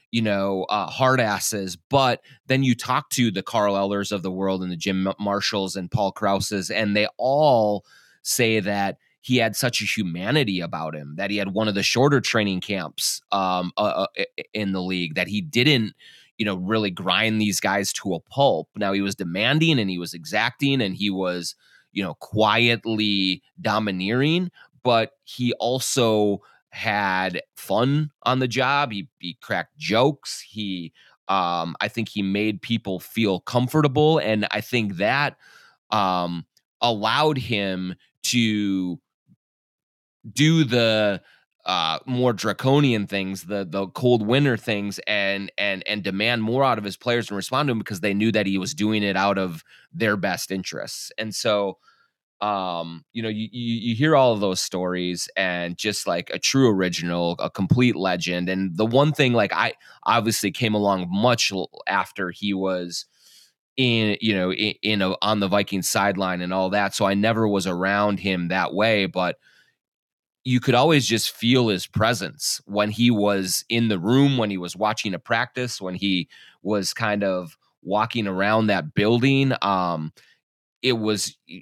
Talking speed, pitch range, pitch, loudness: 170 wpm, 95-120 Hz, 105 Hz, -22 LUFS